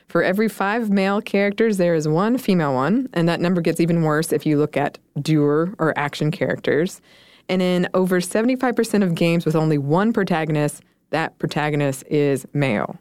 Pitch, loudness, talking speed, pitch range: 170 Hz, -20 LUFS, 175 wpm, 150-195 Hz